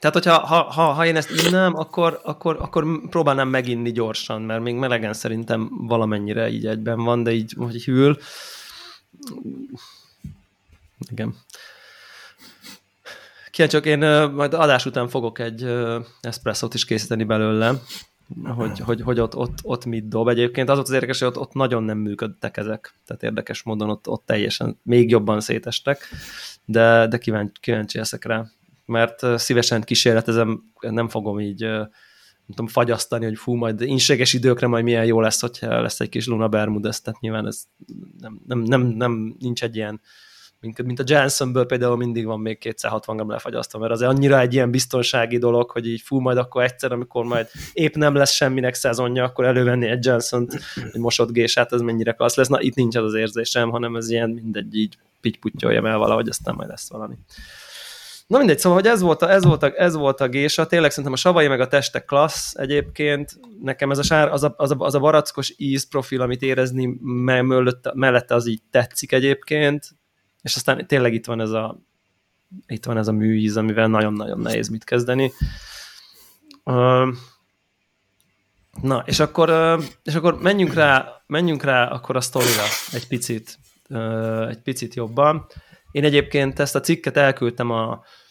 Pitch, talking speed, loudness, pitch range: 120 Hz, 170 wpm, -20 LUFS, 115-140 Hz